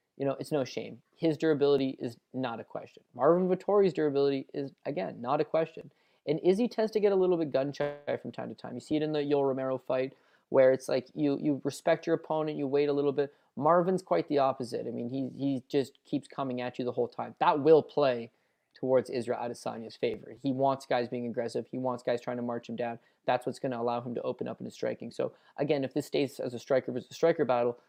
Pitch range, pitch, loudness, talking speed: 125-155 Hz, 135 Hz, -31 LUFS, 245 wpm